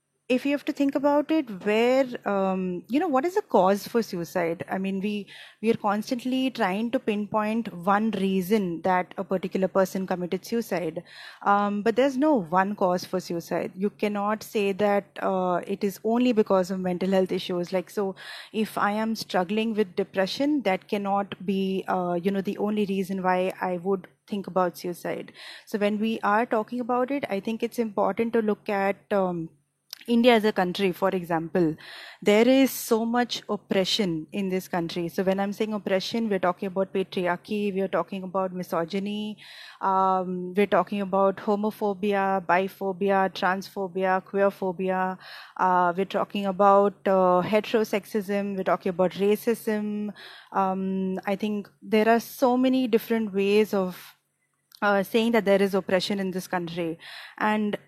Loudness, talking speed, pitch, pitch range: -26 LUFS, 165 wpm, 200 Hz, 185-215 Hz